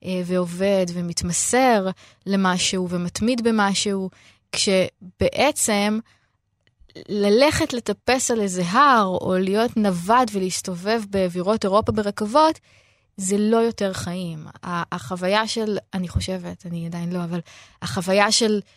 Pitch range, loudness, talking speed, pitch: 180-220 Hz, -21 LUFS, 100 wpm, 195 Hz